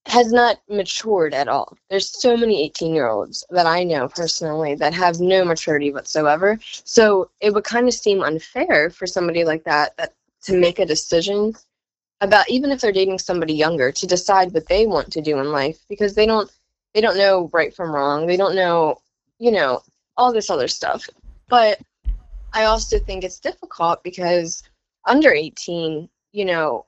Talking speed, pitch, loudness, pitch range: 180 wpm, 185 Hz, -19 LUFS, 160-210 Hz